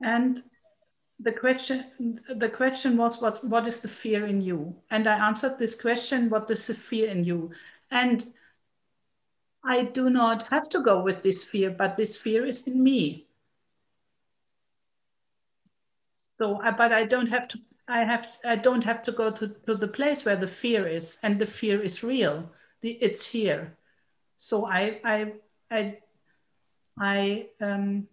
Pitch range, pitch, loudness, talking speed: 210-245 Hz, 225 Hz, -26 LUFS, 165 wpm